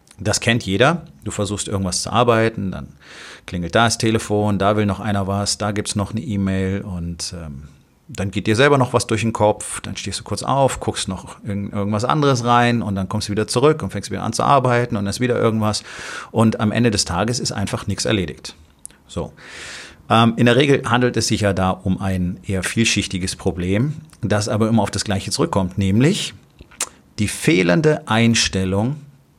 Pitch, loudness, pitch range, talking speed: 105 Hz, -19 LUFS, 95-120 Hz, 200 wpm